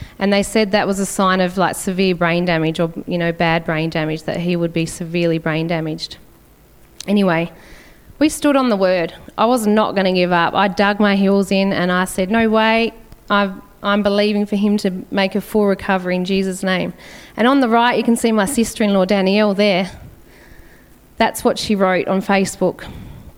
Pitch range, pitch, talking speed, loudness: 175-210 Hz, 195 Hz, 205 wpm, -17 LUFS